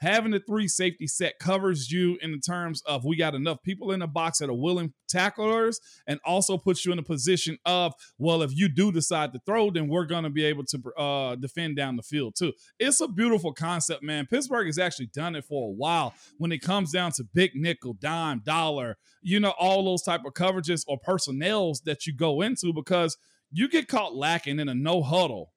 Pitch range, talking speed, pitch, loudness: 150-185 Hz, 220 wpm, 170 Hz, -27 LUFS